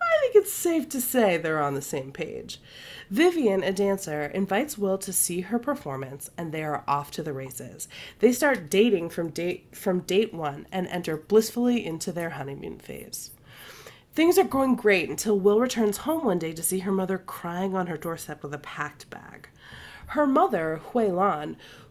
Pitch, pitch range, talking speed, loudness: 190 Hz, 160-230 Hz, 185 wpm, -26 LUFS